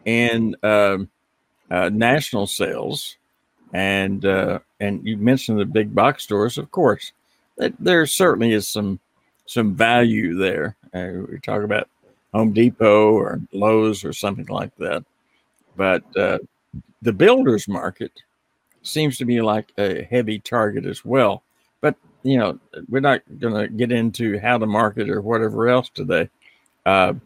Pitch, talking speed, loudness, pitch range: 110 Hz, 145 wpm, -20 LUFS, 105-120 Hz